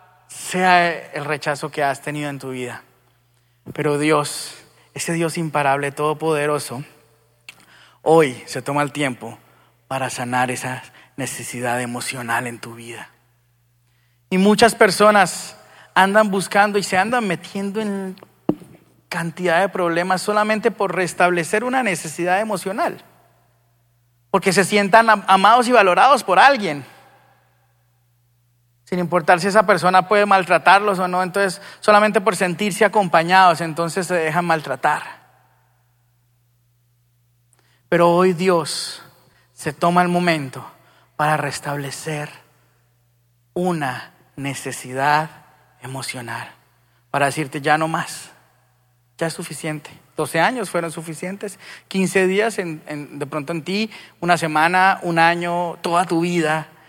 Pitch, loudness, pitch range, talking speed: 155 Hz, -18 LUFS, 125-185 Hz, 120 wpm